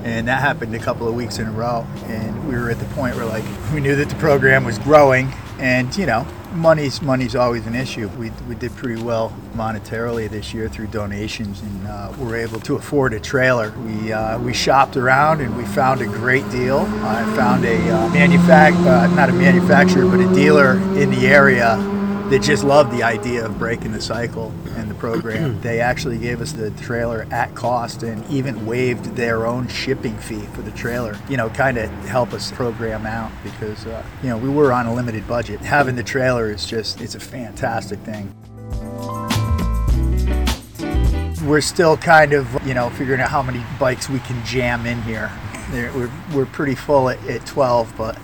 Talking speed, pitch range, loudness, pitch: 195 wpm, 110-135 Hz, -18 LUFS, 120 Hz